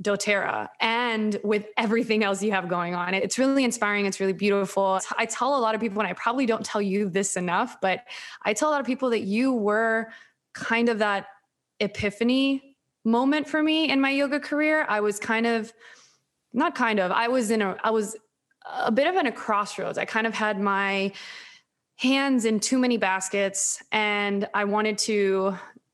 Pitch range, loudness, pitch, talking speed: 200-245 Hz, -24 LUFS, 220 Hz, 190 wpm